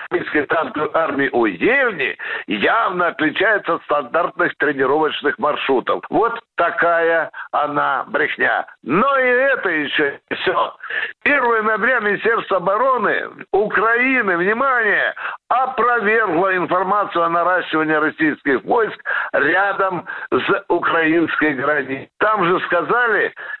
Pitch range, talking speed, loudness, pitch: 165-245 Hz, 100 wpm, -17 LUFS, 200 Hz